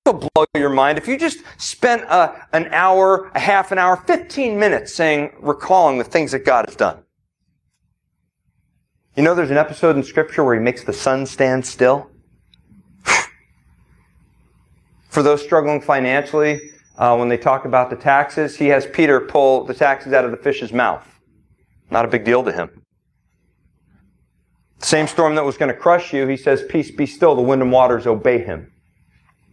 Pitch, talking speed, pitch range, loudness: 145 Hz, 175 wpm, 130-160 Hz, -17 LUFS